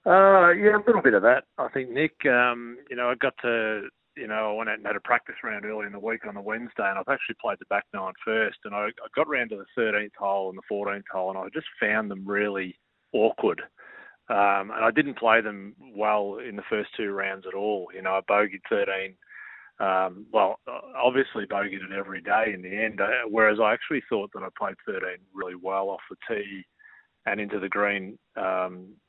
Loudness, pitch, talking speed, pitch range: -26 LUFS, 105 Hz, 225 wpm, 100-115 Hz